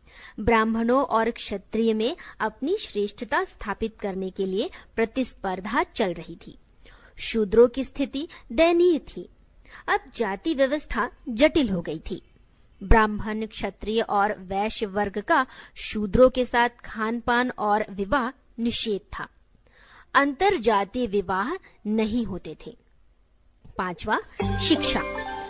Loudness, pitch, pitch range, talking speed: -24 LUFS, 225 Hz, 205-260 Hz, 115 wpm